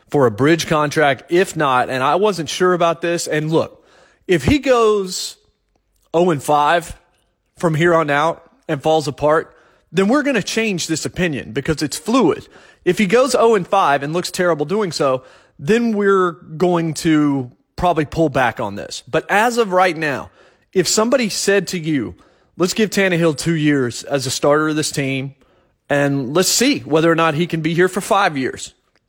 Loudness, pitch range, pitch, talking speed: -17 LUFS, 150-190 Hz, 165 Hz, 190 wpm